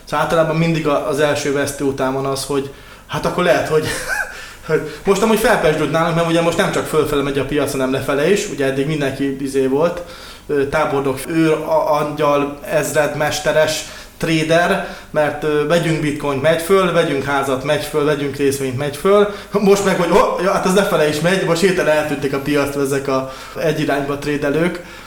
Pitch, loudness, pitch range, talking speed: 150 Hz, -17 LUFS, 140-170 Hz, 175 wpm